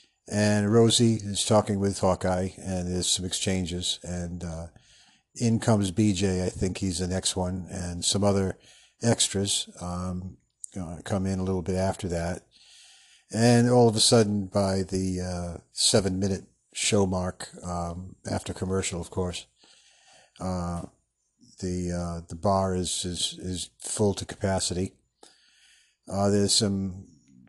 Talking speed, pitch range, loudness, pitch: 140 wpm, 90-100 Hz, -26 LUFS, 95 Hz